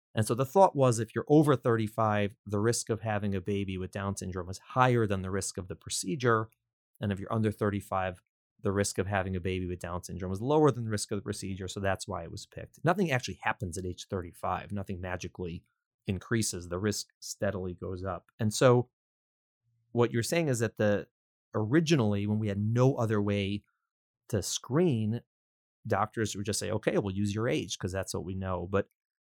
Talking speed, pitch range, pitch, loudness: 205 wpm, 95-115 Hz, 105 Hz, -31 LUFS